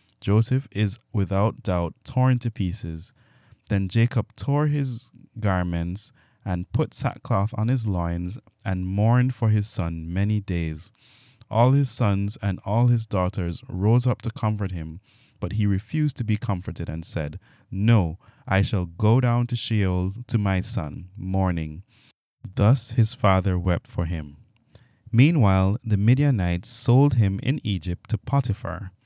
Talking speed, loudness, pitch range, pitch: 145 wpm, -24 LUFS, 95-120 Hz, 105 Hz